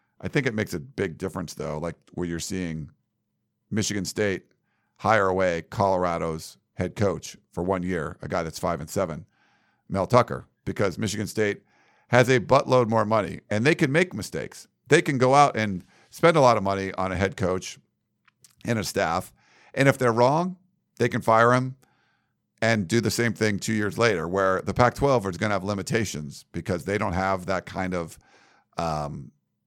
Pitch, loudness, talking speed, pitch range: 105 Hz, -24 LUFS, 190 wpm, 95-120 Hz